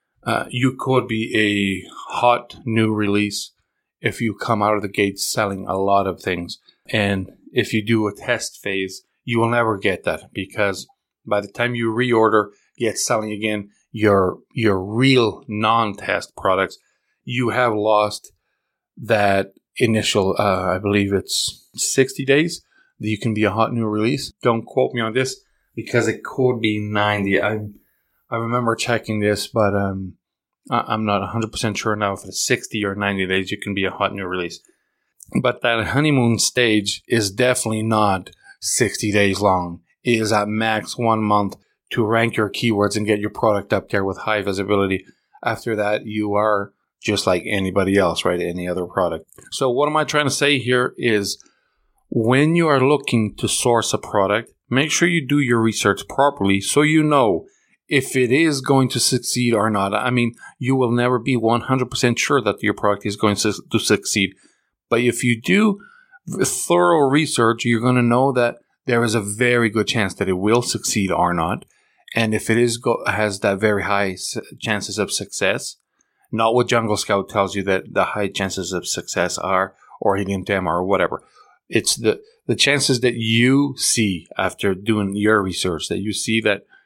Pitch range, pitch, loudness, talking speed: 100-120 Hz, 110 Hz, -19 LUFS, 180 wpm